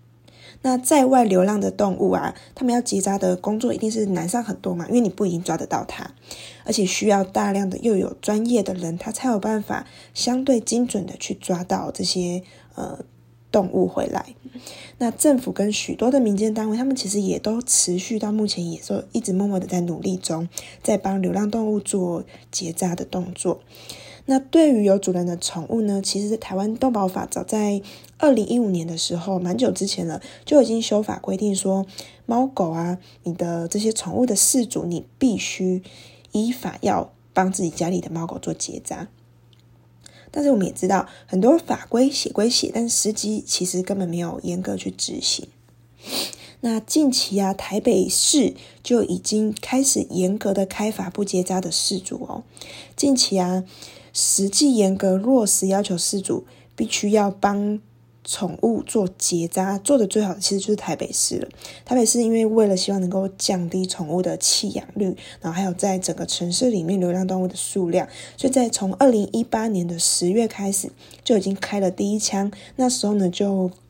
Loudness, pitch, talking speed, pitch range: -21 LUFS, 195 Hz, 270 characters per minute, 180-225 Hz